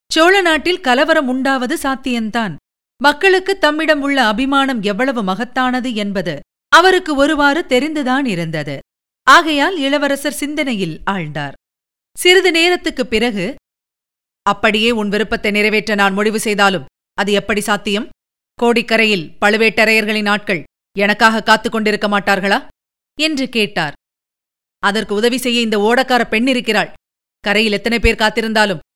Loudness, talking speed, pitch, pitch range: -14 LUFS, 105 wpm, 225 Hz, 205-275 Hz